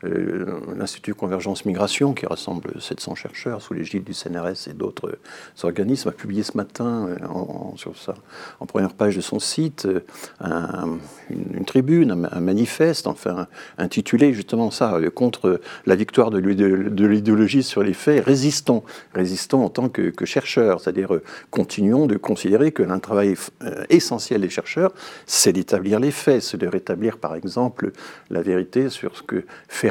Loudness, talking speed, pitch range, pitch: -21 LUFS, 155 wpm, 95-130 Hz, 105 Hz